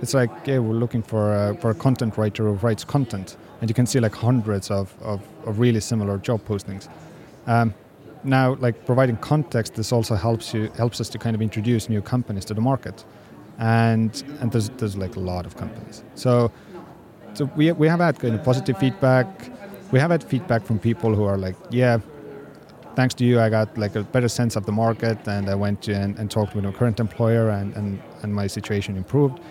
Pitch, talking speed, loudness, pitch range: 115 Hz, 215 wpm, -22 LUFS, 105-125 Hz